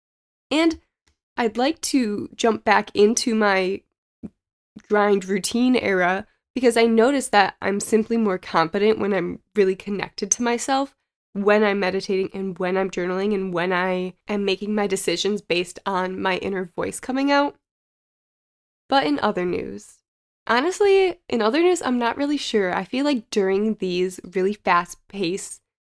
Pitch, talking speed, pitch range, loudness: 205 Hz, 150 wpm, 190-240 Hz, -22 LUFS